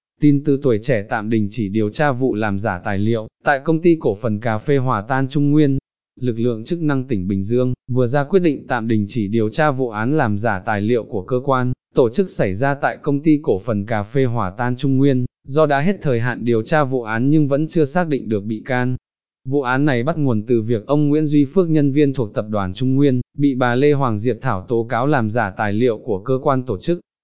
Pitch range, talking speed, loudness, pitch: 115-145 Hz, 260 wpm, -19 LUFS, 130 Hz